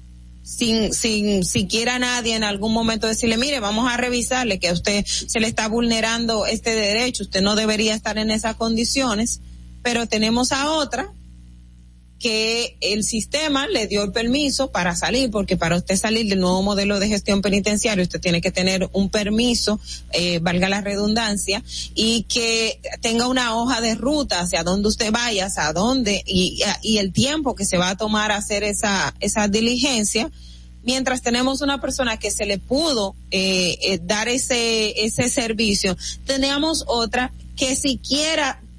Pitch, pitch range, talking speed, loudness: 220 Hz, 195-240 Hz, 165 wpm, -20 LUFS